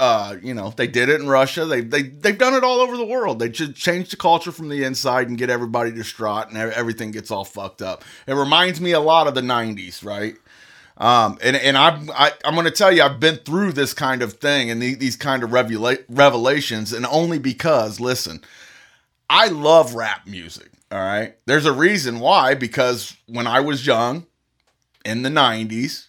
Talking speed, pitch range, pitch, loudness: 205 wpm, 115-155 Hz, 130 Hz, -18 LUFS